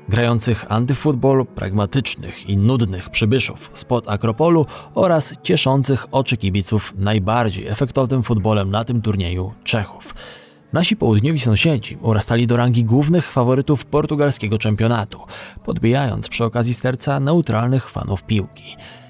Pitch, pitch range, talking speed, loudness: 120 Hz, 105-135 Hz, 115 wpm, -18 LUFS